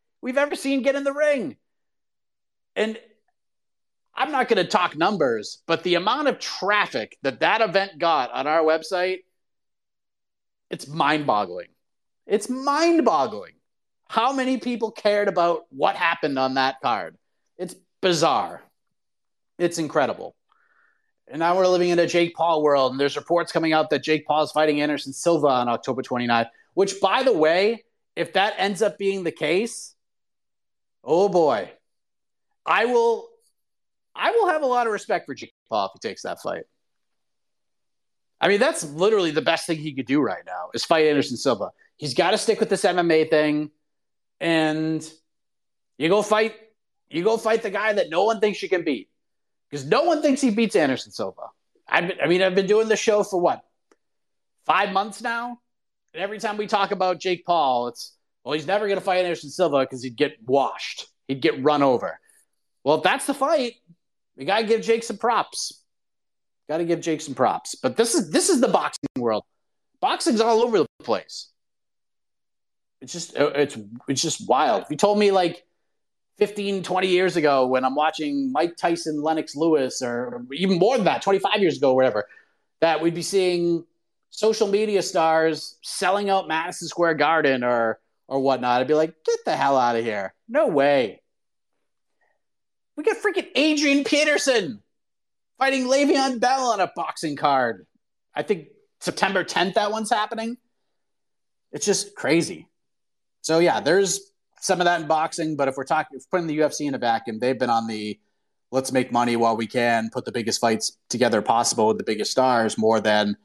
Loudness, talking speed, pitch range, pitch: -22 LUFS, 180 wpm, 150-220 Hz, 170 Hz